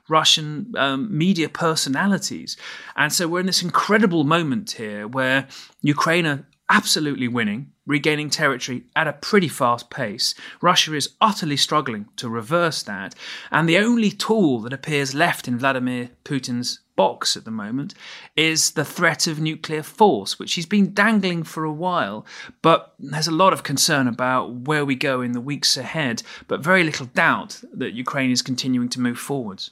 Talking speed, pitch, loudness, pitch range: 170 wpm, 155 Hz, -20 LUFS, 135-175 Hz